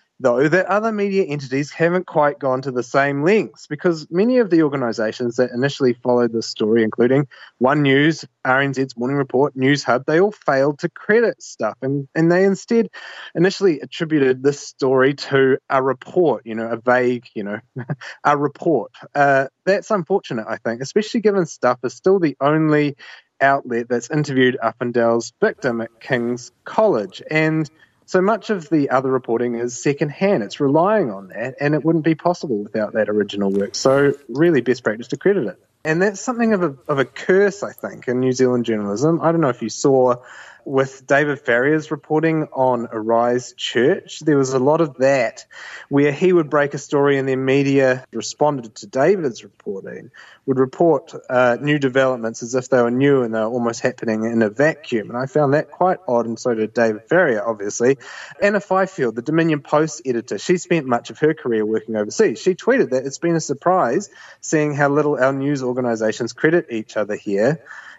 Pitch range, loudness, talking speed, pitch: 120-155 Hz, -19 LUFS, 185 wpm, 135 Hz